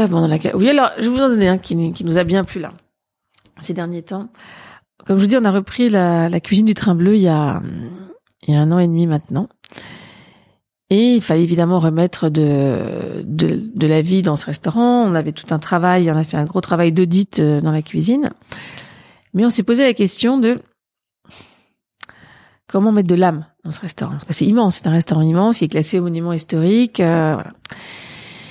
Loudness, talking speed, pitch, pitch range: -16 LUFS, 215 wpm, 180 Hz, 160-205 Hz